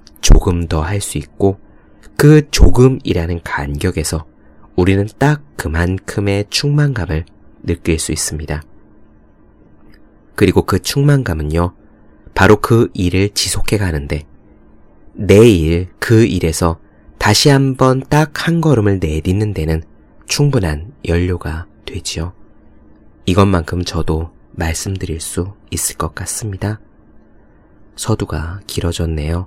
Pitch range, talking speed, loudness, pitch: 80-105 Hz, 225 characters per minute, -15 LUFS, 95 Hz